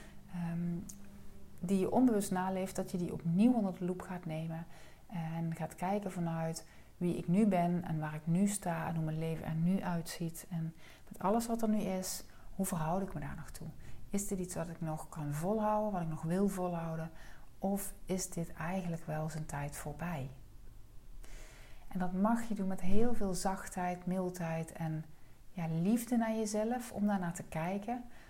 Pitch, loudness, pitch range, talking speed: 180 Hz, -36 LUFS, 160-195 Hz, 185 wpm